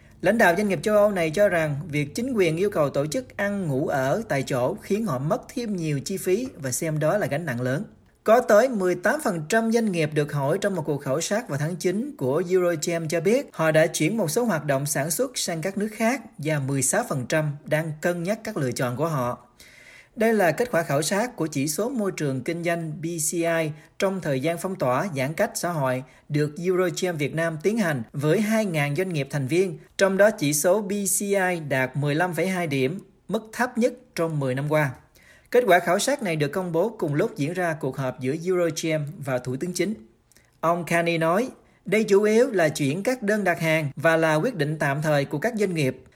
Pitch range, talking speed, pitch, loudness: 150-200 Hz, 220 wpm, 170 Hz, -24 LUFS